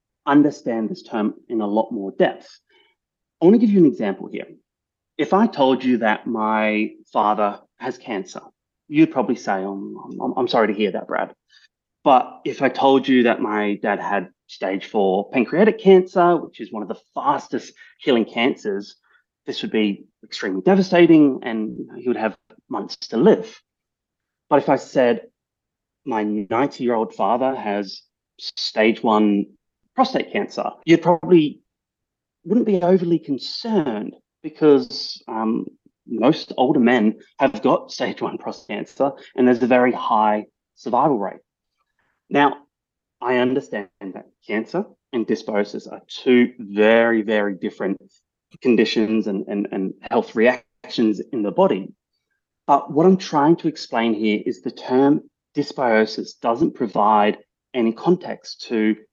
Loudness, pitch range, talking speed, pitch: -20 LUFS, 110-155 Hz, 145 wpm, 125 Hz